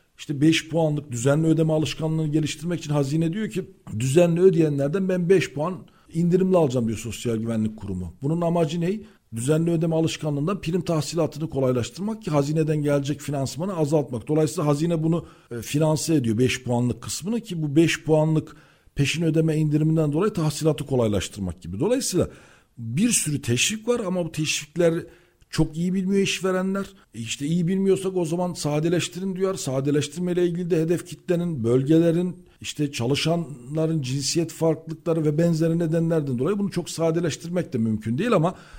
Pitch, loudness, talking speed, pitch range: 160 Hz, -23 LUFS, 150 wpm, 145-175 Hz